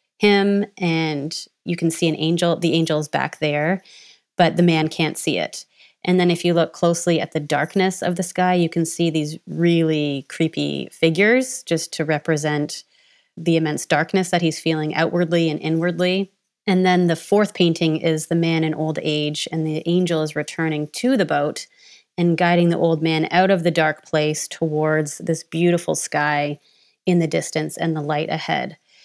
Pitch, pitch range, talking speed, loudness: 165 Hz, 155-175 Hz, 185 wpm, -20 LUFS